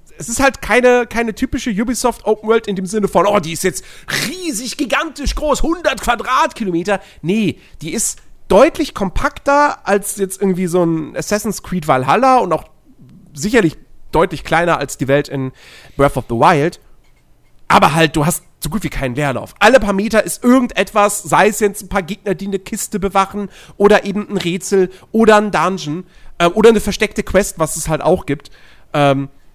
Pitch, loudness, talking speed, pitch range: 200 Hz, -15 LUFS, 185 wpm, 165-230 Hz